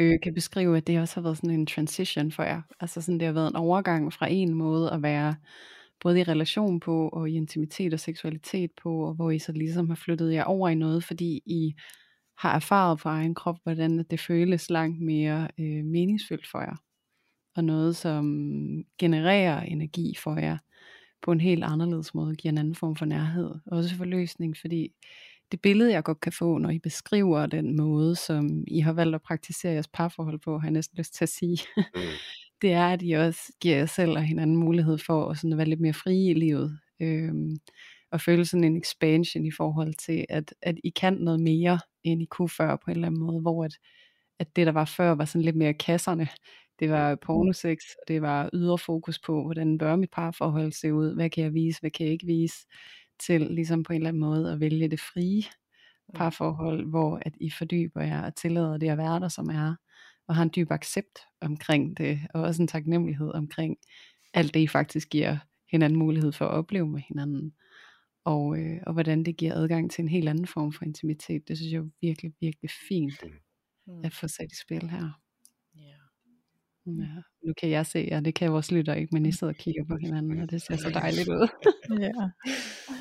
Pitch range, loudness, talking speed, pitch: 155-170 Hz, -28 LUFS, 210 wpm, 165 Hz